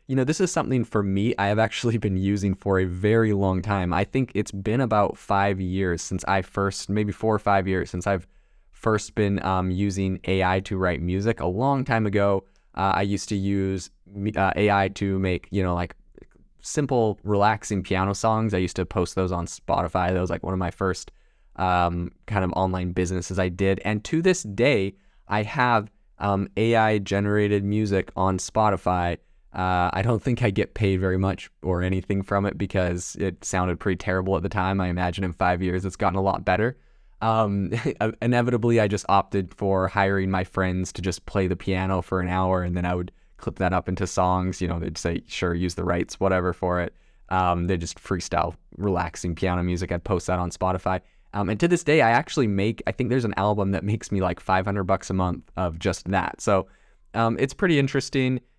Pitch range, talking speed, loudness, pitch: 90-105 Hz, 210 wpm, -24 LUFS, 95 Hz